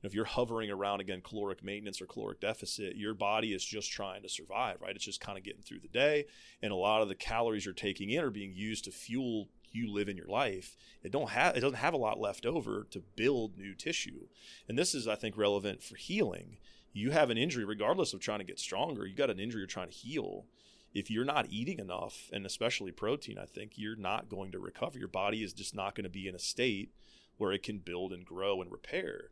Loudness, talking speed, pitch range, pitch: -36 LUFS, 245 wpm, 95-110 Hz, 100 Hz